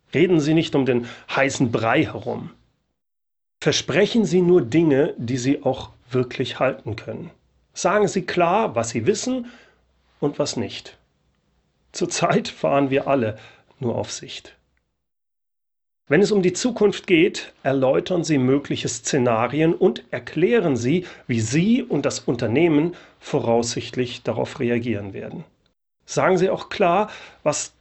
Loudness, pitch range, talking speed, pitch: -21 LUFS, 120-170 Hz, 130 wpm, 135 Hz